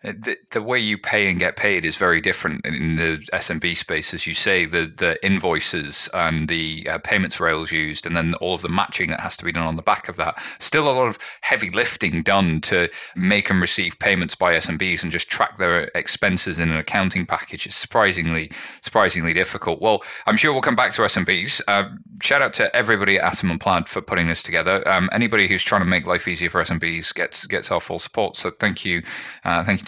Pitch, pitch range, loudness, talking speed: 85 Hz, 80-95 Hz, -20 LUFS, 225 wpm